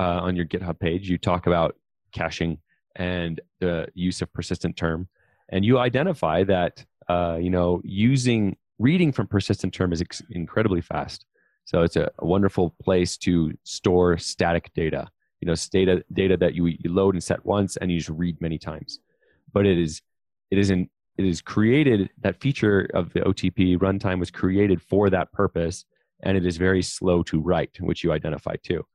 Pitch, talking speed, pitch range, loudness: 90 Hz, 185 wpm, 85-95 Hz, -24 LUFS